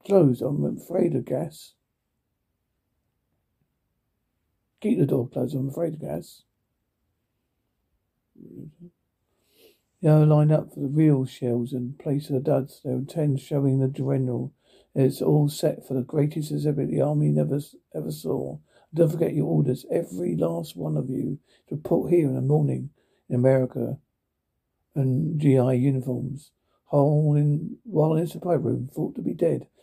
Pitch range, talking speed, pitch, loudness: 125-150 Hz, 155 wpm, 135 Hz, -25 LUFS